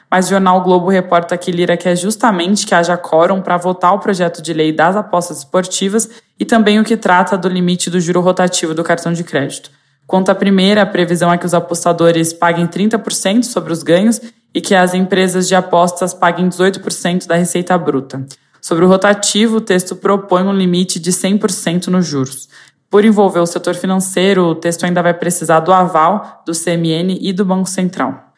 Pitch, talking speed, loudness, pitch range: 180 Hz, 195 wpm, -13 LUFS, 170-190 Hz